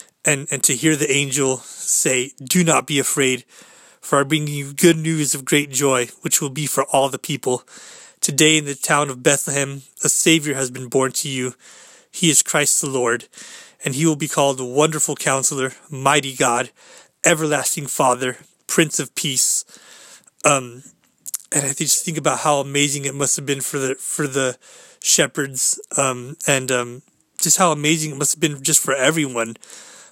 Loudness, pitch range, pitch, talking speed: -18 LUFS, 135-155 Hz, 145 Hz, 180 wpm